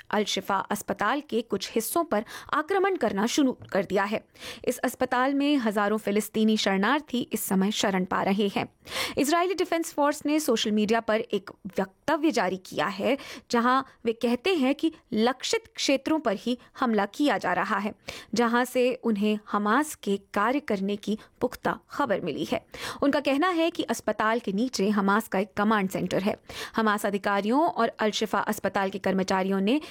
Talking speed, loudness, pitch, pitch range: 170 wpm, -26 LUFS, 225 Hz, 205-265 Hz